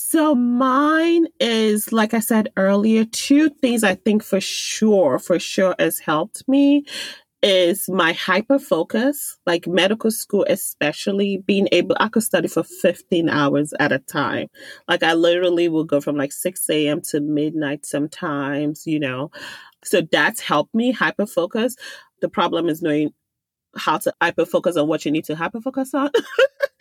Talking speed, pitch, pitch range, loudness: 165 wpm, 190 Hz, 160-235 Hz, -19 LUFS